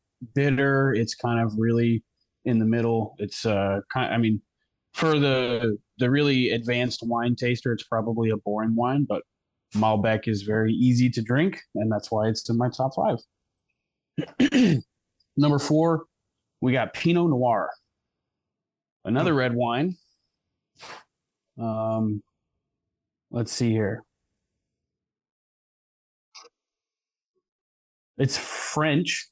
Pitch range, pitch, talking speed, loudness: 110-135 Hz, 120 Hz, 115 wpm, -25 LUFS